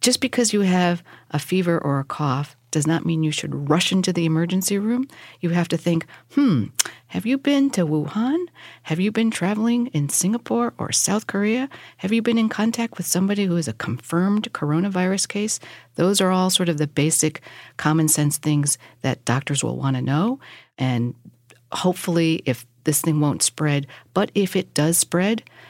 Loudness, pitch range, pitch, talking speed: -21 LUFS, 150-205 Hz, 170 Hz, 185 wpm